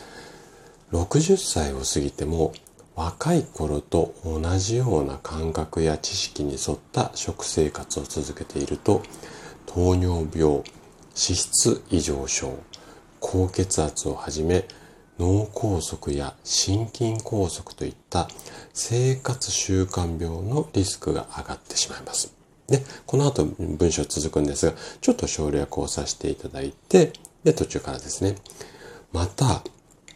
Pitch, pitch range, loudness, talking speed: 85 Hz, 75-100 Hz, -25 LUFS, 235 characters per minute